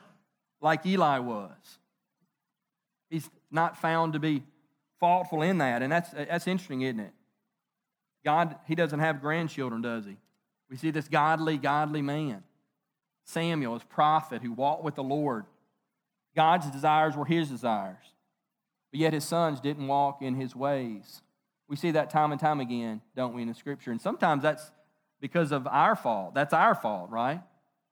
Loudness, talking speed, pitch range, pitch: -29 LUFS, 160 wpm, 140-160 Hz, 150 Hz